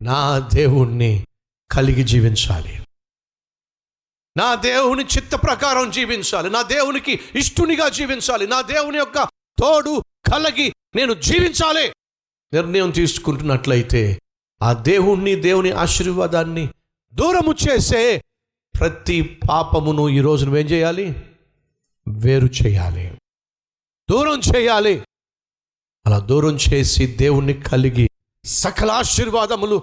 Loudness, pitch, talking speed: -17 LUFS, 160 Hz, 90 wpm